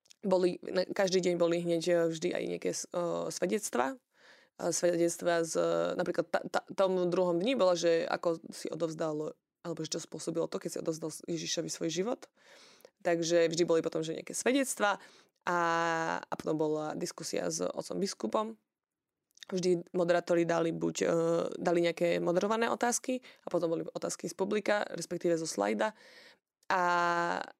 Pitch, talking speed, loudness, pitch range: 170 Hz, 150 wpm, -32 LUFS, 165-180 Hz